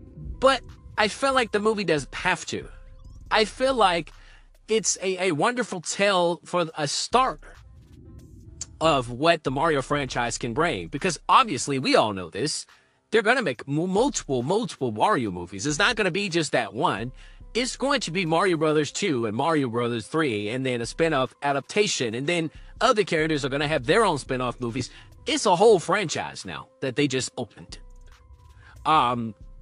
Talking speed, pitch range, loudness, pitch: 180 wpm, 120-180 Hz, -24 LUFS, 145 Hz